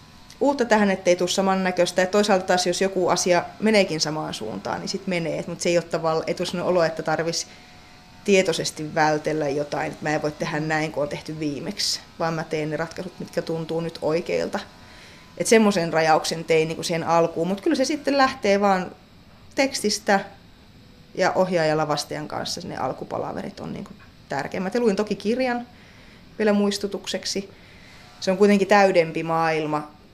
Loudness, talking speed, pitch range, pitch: -23 LUFS, 160 wpm, 160-200 Hz, 175 Hz